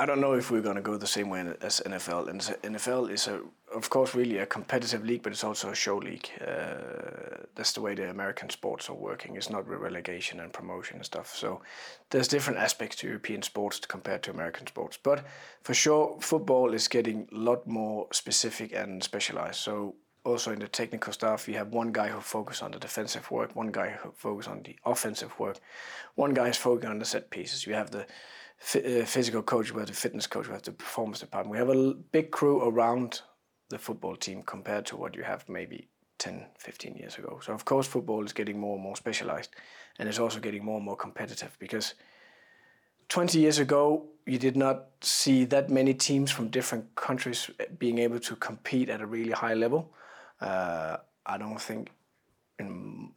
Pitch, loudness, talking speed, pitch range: 120 Hz, -31 LUFS, 205 wpm, 110-135 Hz